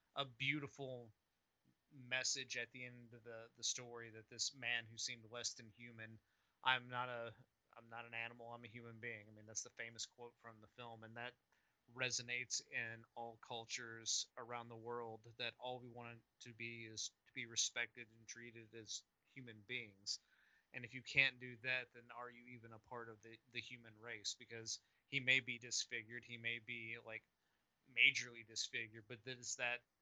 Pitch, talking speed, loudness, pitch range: 120 Hz, 190 wpm, -44 LUFS, 115-125 Hz